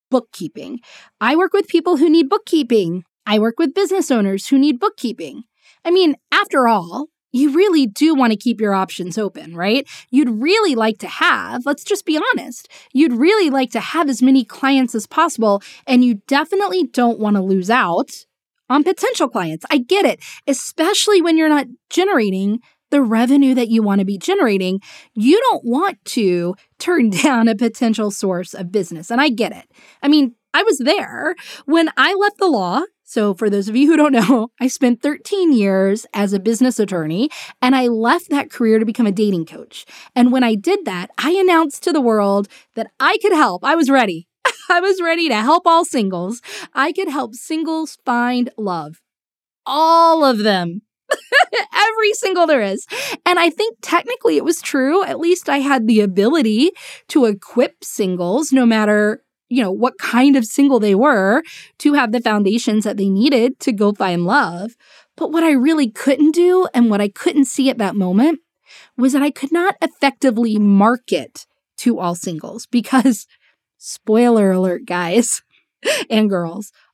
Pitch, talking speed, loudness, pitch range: 260 Hz, 180 wpm, -16 LUFS, 215-320 Hz